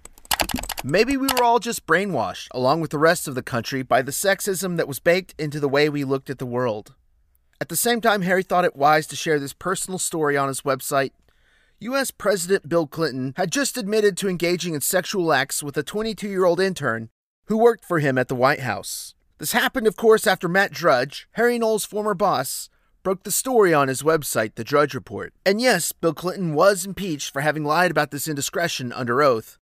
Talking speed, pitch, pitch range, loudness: 210 wpm, 165 Hz, 140-195 Hz, -22 LUFS